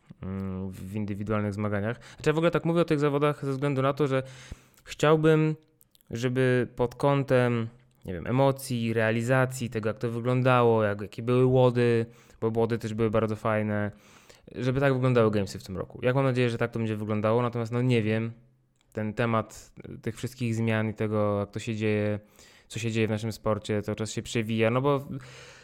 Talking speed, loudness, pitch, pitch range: 190 wpm, -27 LUFS, 115 Hz, 110-130 Hz